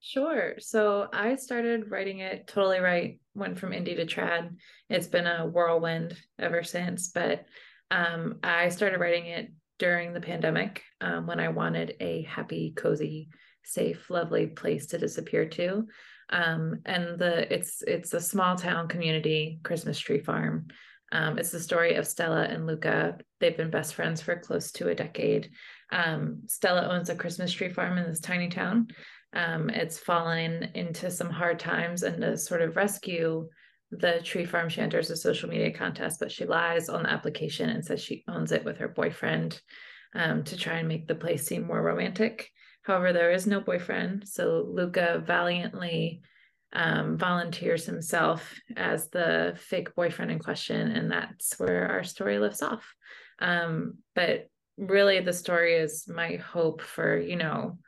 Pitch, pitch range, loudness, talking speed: 175 Hz, 165-185 Hz, -29 LUFS, 165 wpm